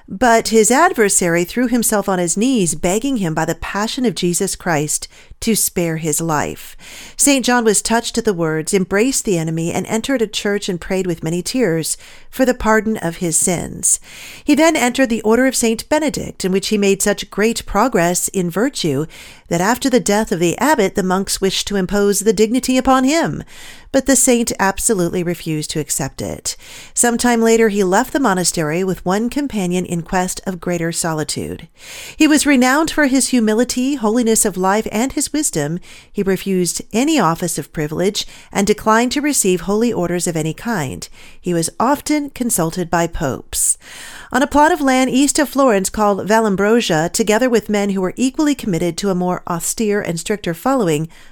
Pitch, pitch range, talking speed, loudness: 210 Hz, 180-250 Hz, 185 wpm, -16 LUFS